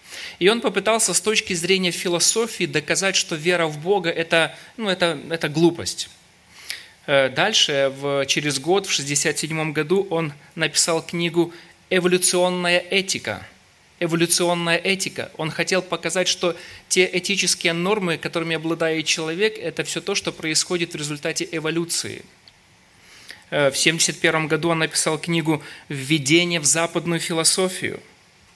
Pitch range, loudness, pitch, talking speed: 160-180 Hz, -20 LUFS, 170 Hz, 125 wpm